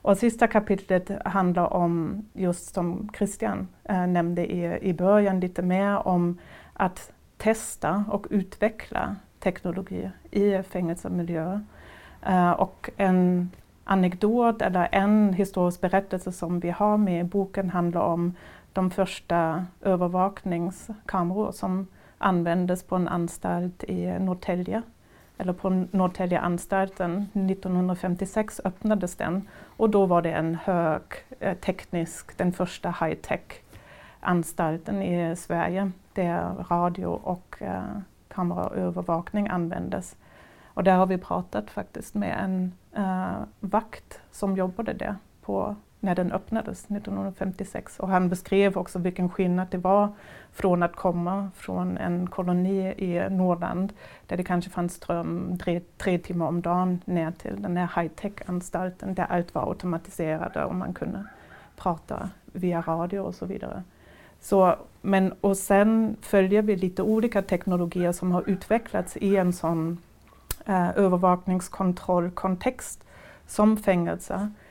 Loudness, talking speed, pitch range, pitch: -26 LUFS, 125 wpm, 175-200 Hz, 185 Hz